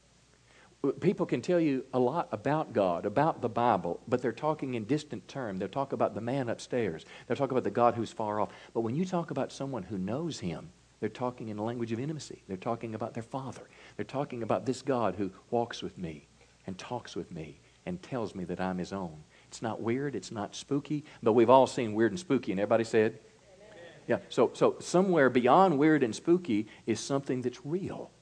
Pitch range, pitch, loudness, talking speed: 110-140 Hz, 120 Hz, -31 LUFS, 215 wpm